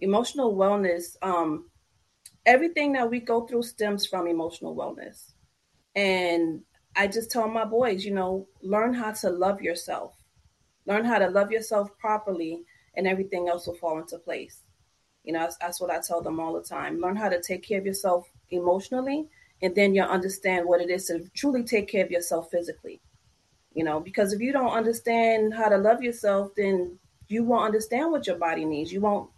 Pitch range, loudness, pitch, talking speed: 175-225 Hz, -26 LUFS, 195 Hz, 190 wpm